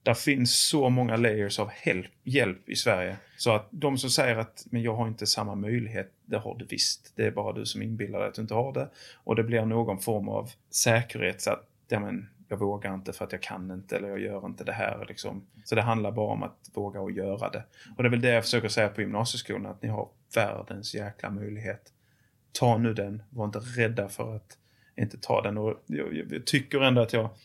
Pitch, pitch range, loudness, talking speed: 115 Hz, 105-120 Hz, -29 LUFS, 235 wpm